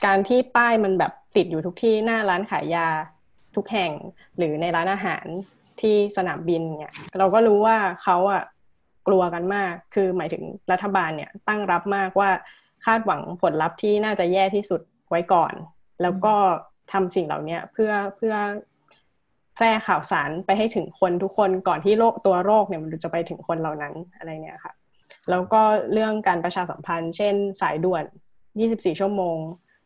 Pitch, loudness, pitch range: 190 Hz, -23 LUFS, 170-205 Hz